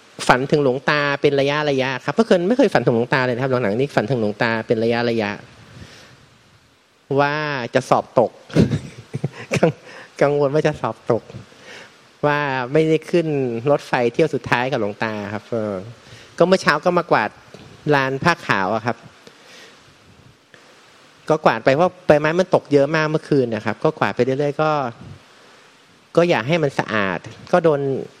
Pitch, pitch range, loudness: 135 Hz, 120-150 Hz, -19 LUFS